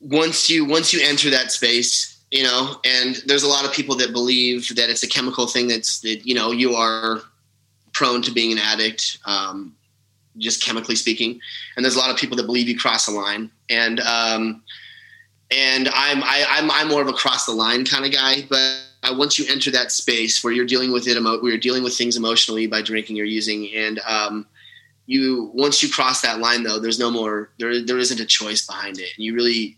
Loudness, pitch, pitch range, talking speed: -18 LUFS, 120 Hz, 110-130 Hz, 220 wpm